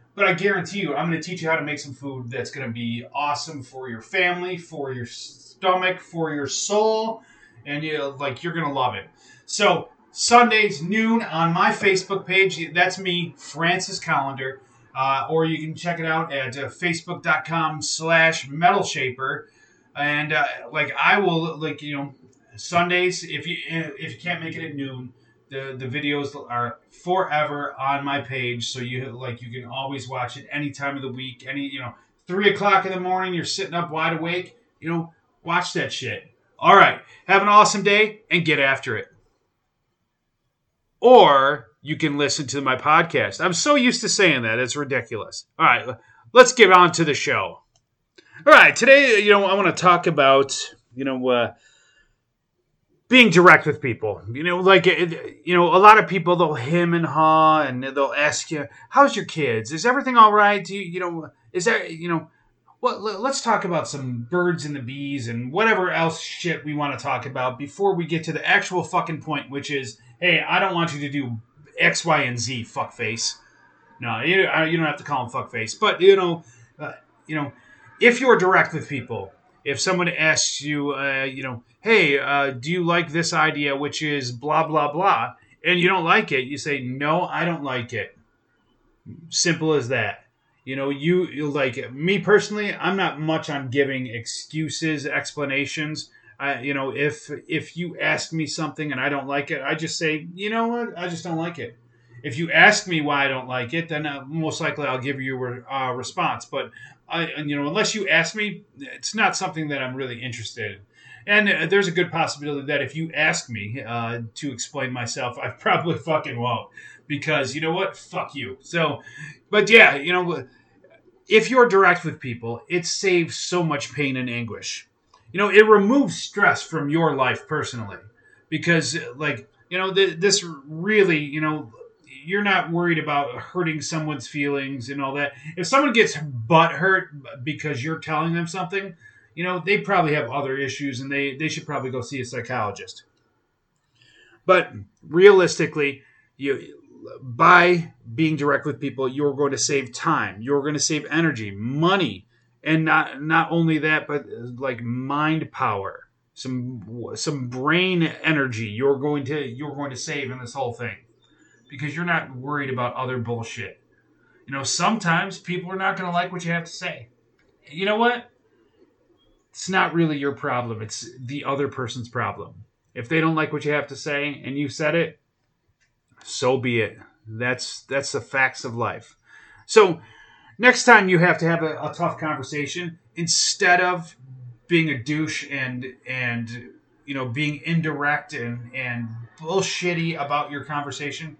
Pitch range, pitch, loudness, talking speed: 135-175 Hz, 150 Hz, -21 LUFS, 185 wpm